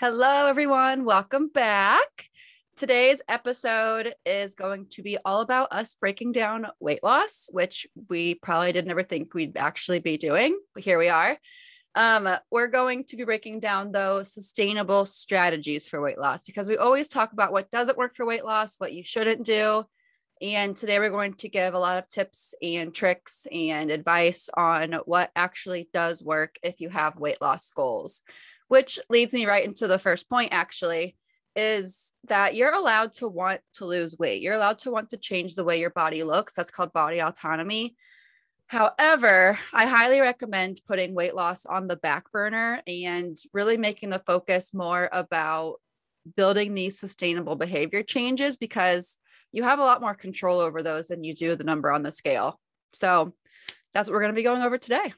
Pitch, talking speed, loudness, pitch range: 200 Hz, 180 wpm, -25 LUFS, 175-230 Hz